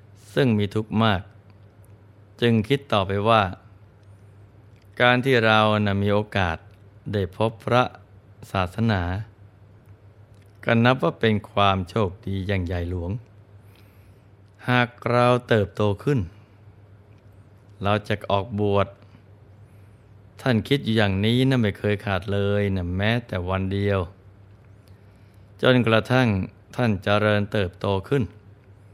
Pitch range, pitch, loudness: 100-110 Hz, 105 Hz, -23 LUFS